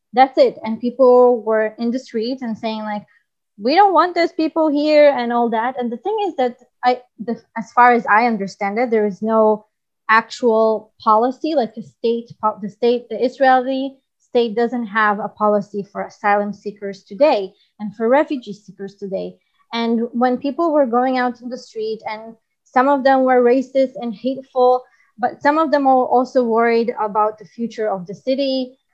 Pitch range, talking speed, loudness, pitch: 215-260 Hz, 185 wpm, -18 LUFS, 240 Hz